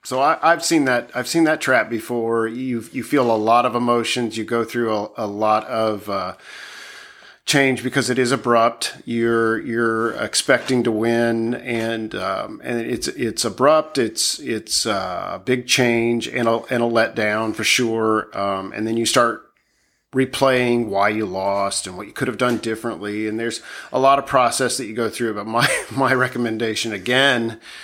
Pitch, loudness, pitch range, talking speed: 115 Hz, -20 LUFS, 110-125 Hz, 180 wpm